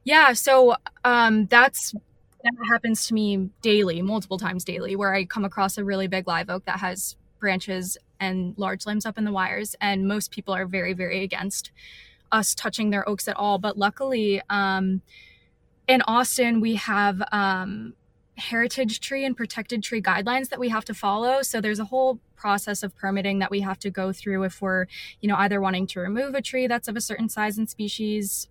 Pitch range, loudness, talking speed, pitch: 190-230 Hz, -24 LUFS, 195 wpm, 205 Hz